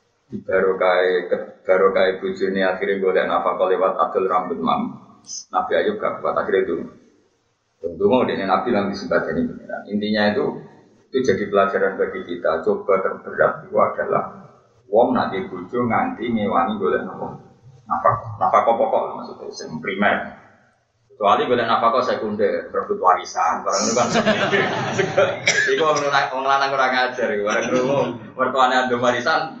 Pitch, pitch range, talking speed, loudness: 130 Hz, 95-160 Hz, 145 wpm, -20 LUFS